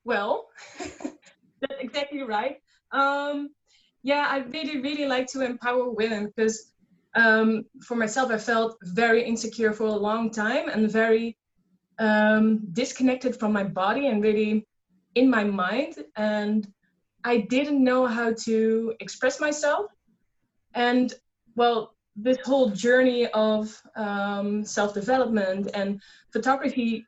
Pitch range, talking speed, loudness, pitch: 215-255 Hz, 120 wpm, -25 LUFS, 225 Hz